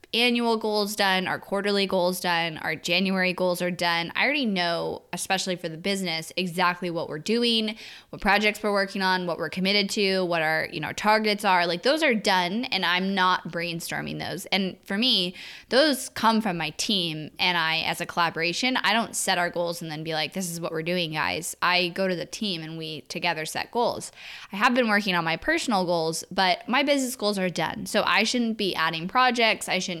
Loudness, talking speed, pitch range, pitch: -24 LUFS, 215 wpm, 170-215 Hz, 185 Hz